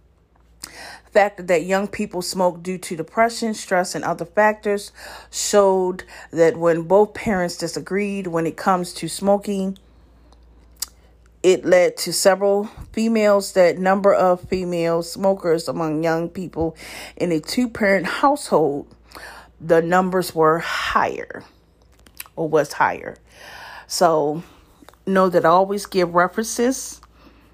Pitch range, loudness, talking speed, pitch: 165-200 Hz, -20 LUFS, 120 wpm, 180 Hz